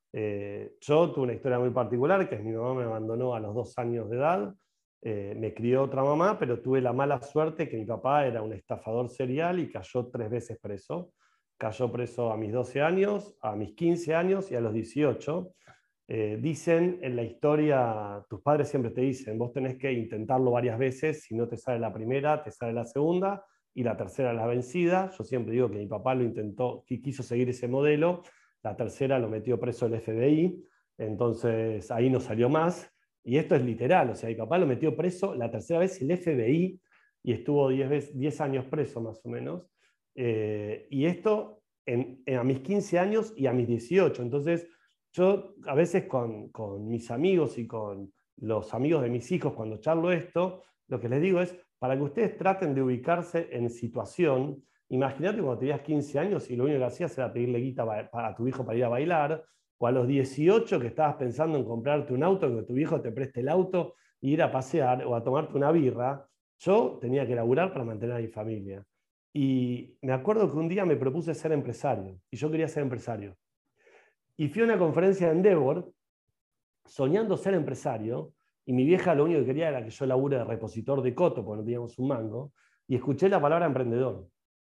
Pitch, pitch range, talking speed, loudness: 130 Hz, 120-155 Hz, 205 wpm, -29 LUFS